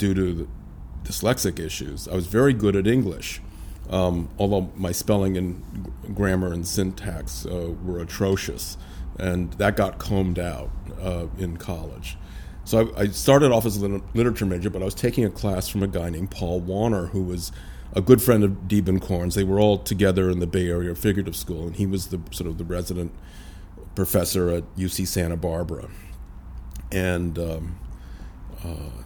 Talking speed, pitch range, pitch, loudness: 175 wpm, 85-100 Hz, 90 Hz, -24 LUFS